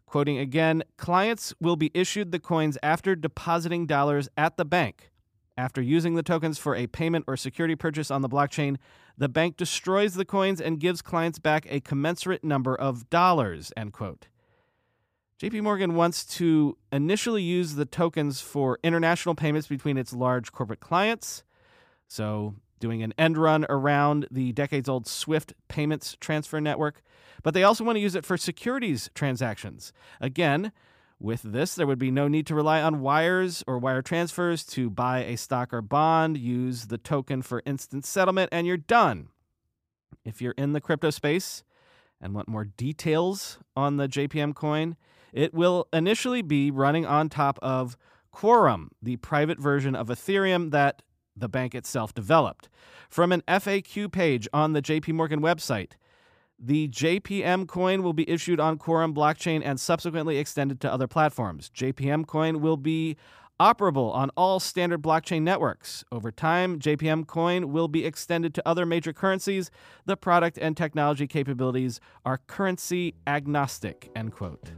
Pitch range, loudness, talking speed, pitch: 130-170 Hz, -26 LUFS, 160 wpm, 155 Hz